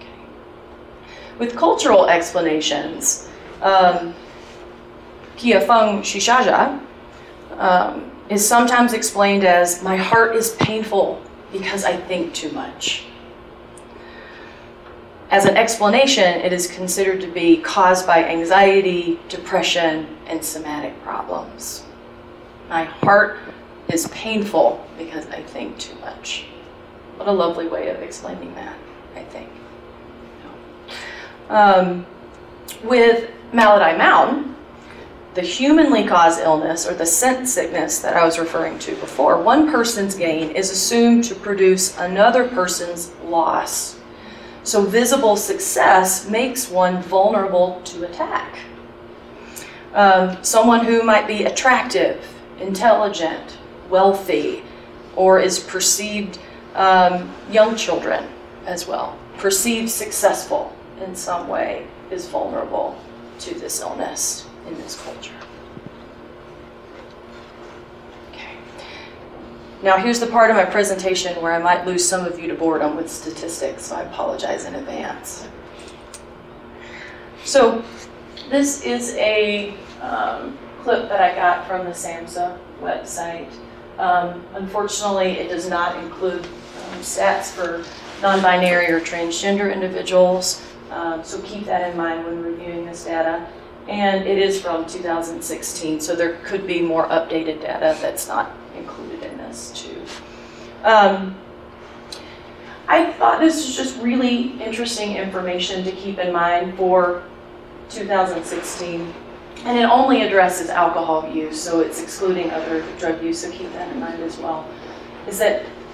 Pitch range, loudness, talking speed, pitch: 170-210 Hz, -18 LUFS, 120 wpm, 185 Hz